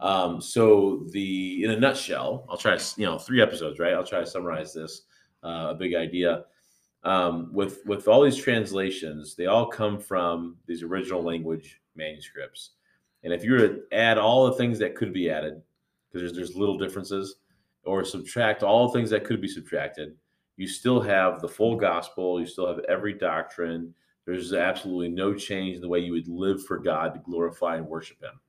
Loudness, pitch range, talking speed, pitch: -26 LUFS, 85-105 Hz, 190 wpm, 95 Hz